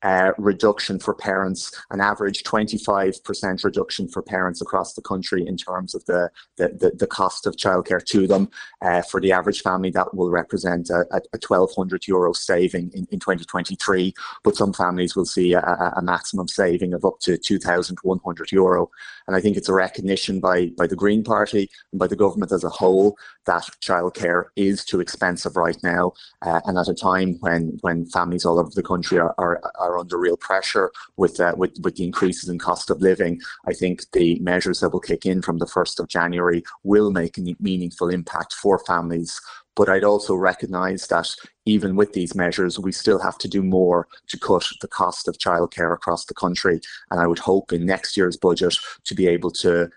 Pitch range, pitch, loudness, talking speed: 85-95 Hz, 90 Hz, -21 LUFS, 200 wpm